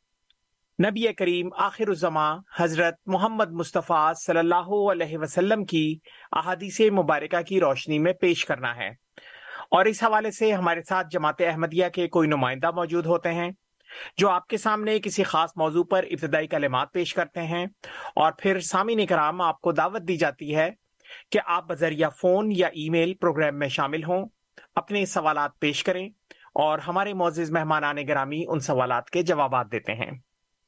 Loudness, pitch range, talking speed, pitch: -25 LUFS, 155-190 Hz, 165 wpm, 175 Hz